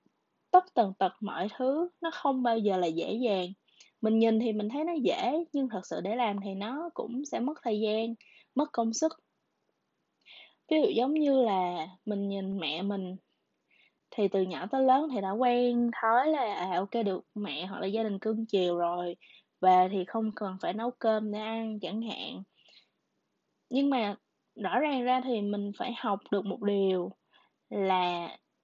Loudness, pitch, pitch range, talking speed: -30 LUFS, 220 Hz, 195-250 Hz, 185 wpm